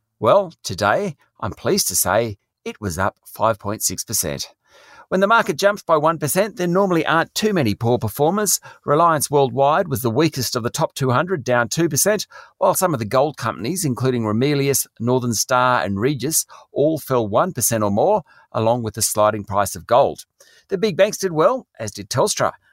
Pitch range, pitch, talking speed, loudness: 115-170 Hz, 130 Hz, 175 wpm, -19 LUFS